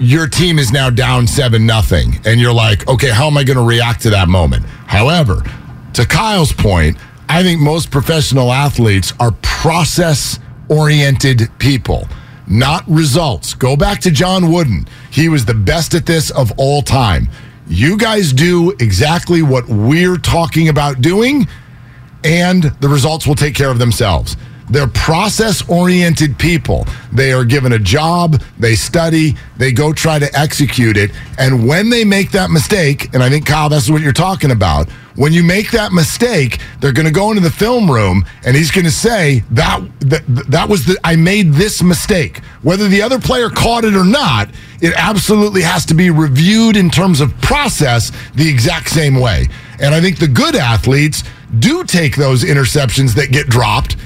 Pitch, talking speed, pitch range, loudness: 145 Hz, 180 wpm, 125-170 Hz, -11 LUFS